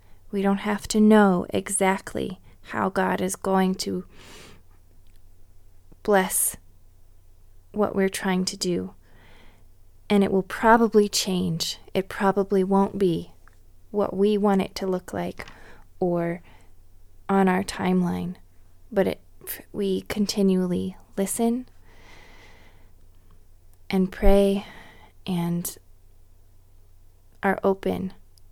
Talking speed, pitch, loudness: 100 wpm, 170 Hz, -24 LUFS